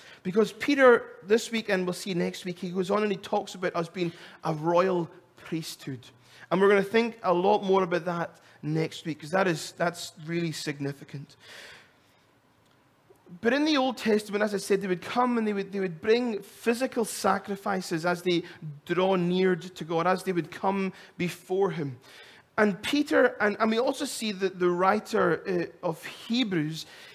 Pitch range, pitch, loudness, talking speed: 170-210 Hz, 190 Hz, -27 LUFS, 185 wpm